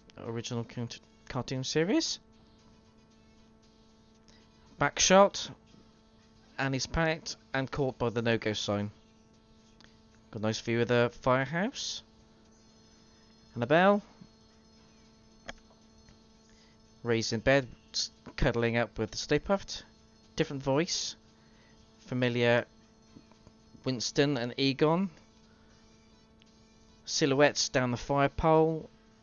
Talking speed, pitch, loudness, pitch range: 95 wpm, 115 Hz, -30 LUFS, 110-135 Hz